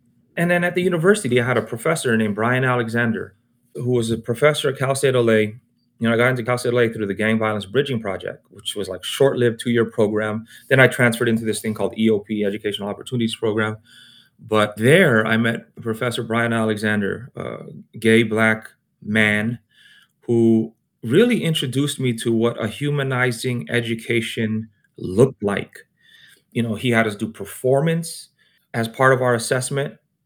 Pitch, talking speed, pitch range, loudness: 115 Hz, 170 wpm, 110-130 Hz, -20 LUFS